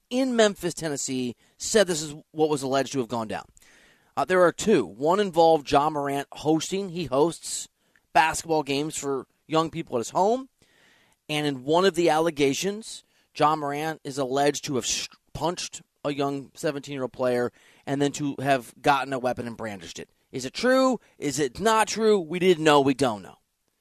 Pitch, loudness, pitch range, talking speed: 150 Hz, -25 LUFS, 140-175 Hz, 185 wpm